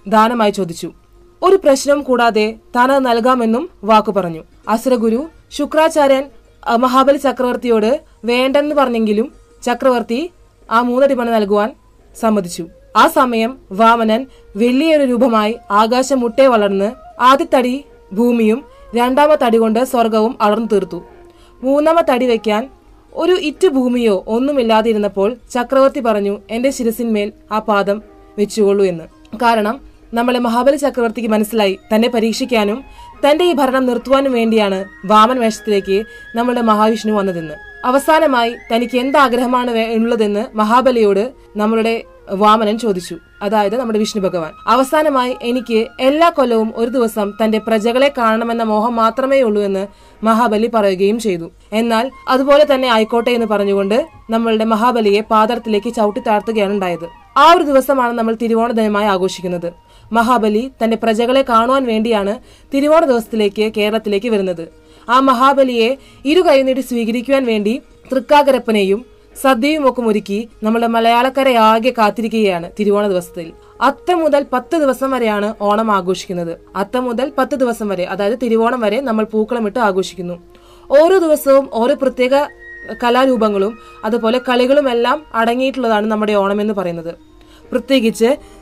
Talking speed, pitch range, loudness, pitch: 115 wpm, 210-260 Hz, -14 LUFS, 230 Hz